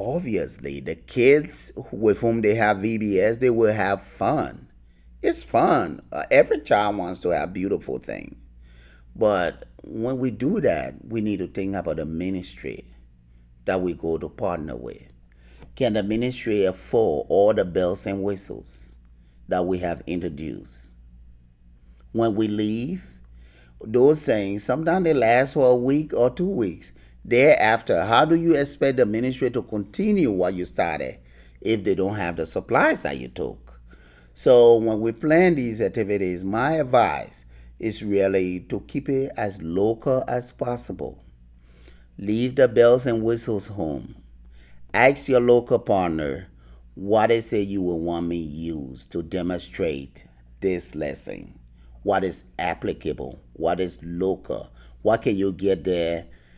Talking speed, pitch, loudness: 145 wpm, 90 Hz, -23 LUFS